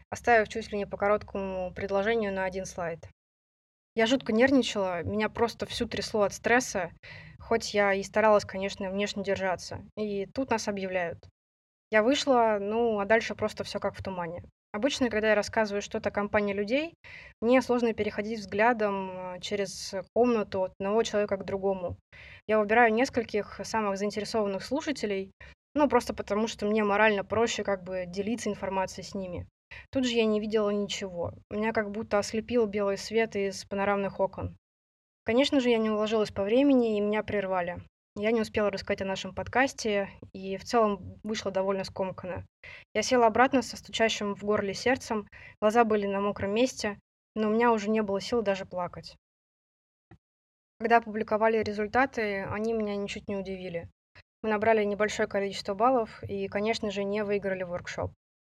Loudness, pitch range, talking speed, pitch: -28 LUFS, 195-225 Hz, 160 wpm, 210 Hz